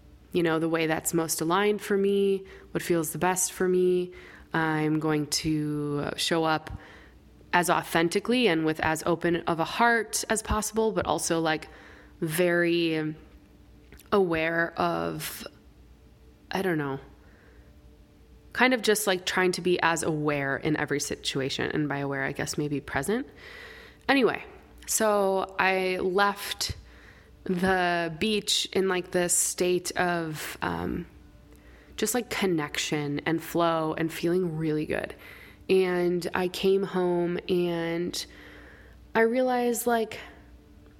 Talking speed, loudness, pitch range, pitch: 130 wpm, -27 LUFS, 150-190 Hz, 170 Hz